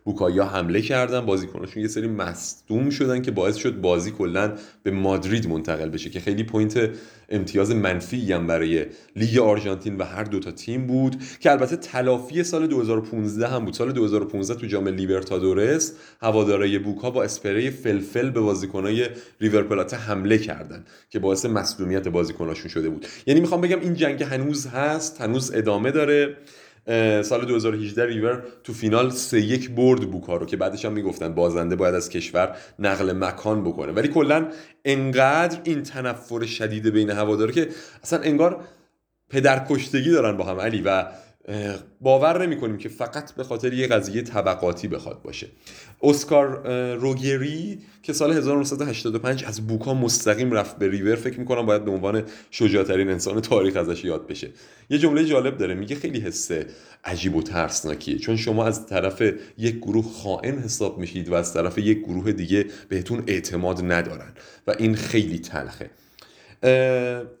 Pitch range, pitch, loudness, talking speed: 100-130 Hz, 110 Hz, -23 LUFS, 155 wpm